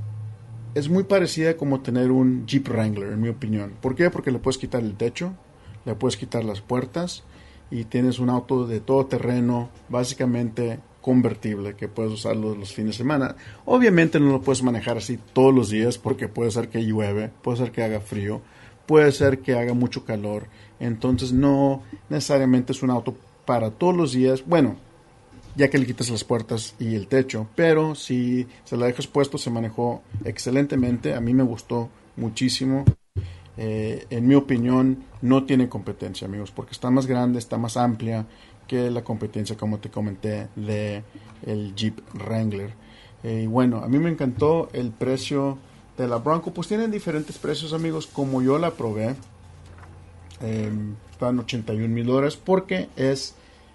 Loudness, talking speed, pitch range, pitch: -23 LUFS, 170 wpm, 110-130 Hz, 120 Hz